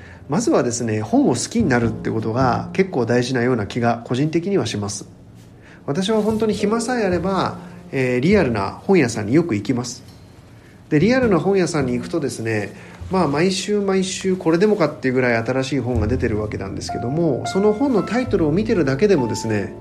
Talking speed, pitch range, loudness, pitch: 320 characters per minute, 115-190 Hz, -19 LUFS, 130 Hz